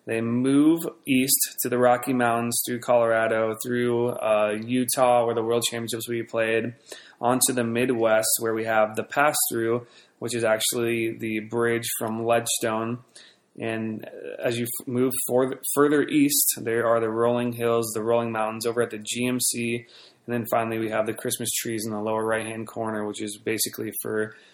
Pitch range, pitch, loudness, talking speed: 110-120 Hz, 115 Hz, -24 LUFS, 175 wpm